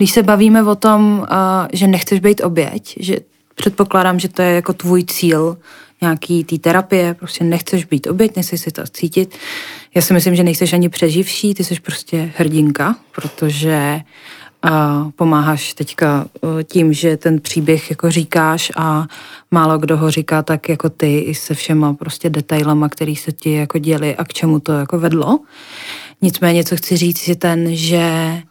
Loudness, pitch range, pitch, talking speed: -15 LUFS, 155-180 Hz, 170 Hz, 165 wpm